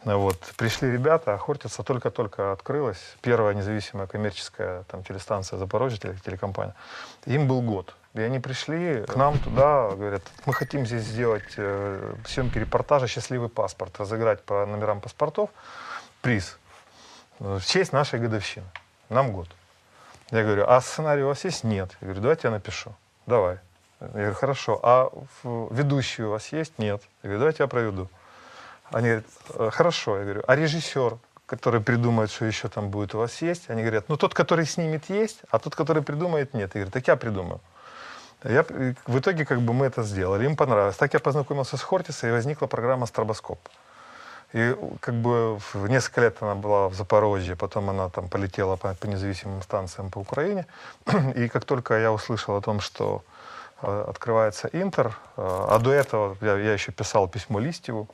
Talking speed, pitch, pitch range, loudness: 165 wpm, 115 Hz, 100-135 Hz, -26 LUFS